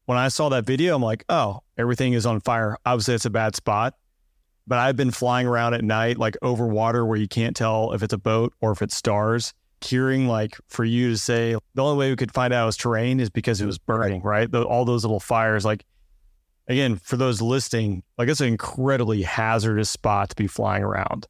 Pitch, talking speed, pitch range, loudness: 115 Hz, 230 wpm, 110-125 Hz, -23 LUFS